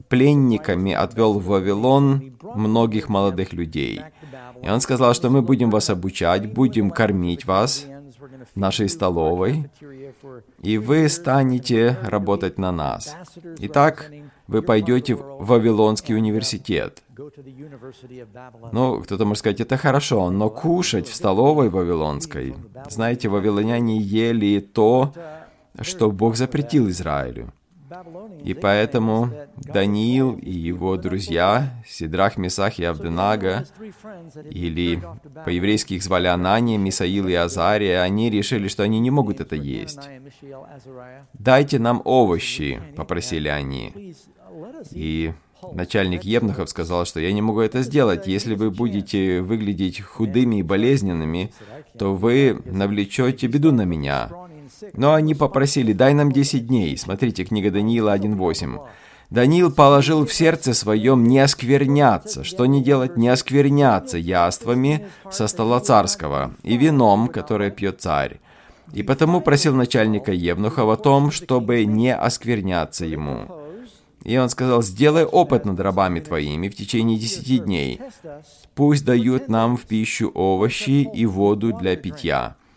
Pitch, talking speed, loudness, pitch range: 115 Hz, 125 wpm, -19 LUFS, 100-135 Hz